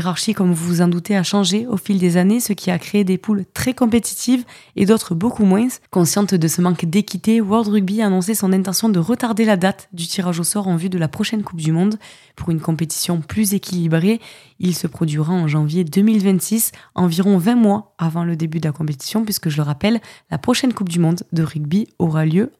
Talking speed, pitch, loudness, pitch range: 220 wpm, 190 Hz, -18 LUFS, 170-215 Hz